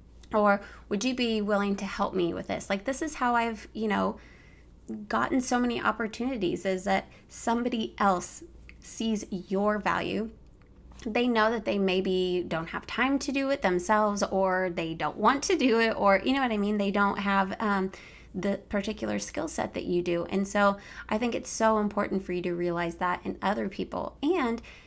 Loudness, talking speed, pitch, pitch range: -28 LUFS, 195 wpm, 205 Hz, 190-230 Hz